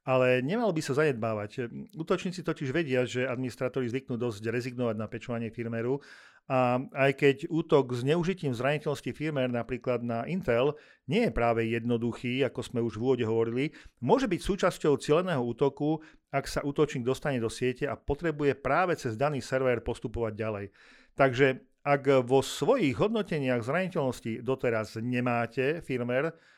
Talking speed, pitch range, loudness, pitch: 145 wpm, 120-150 Hz, -29 LUFS, 130 Hz